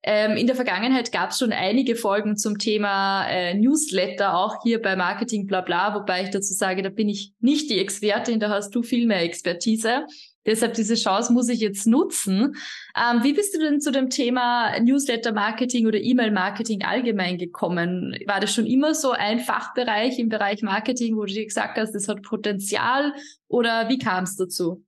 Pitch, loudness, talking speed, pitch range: 220 Hz, -22 LUFS, 185 wpm, 200-245 Hz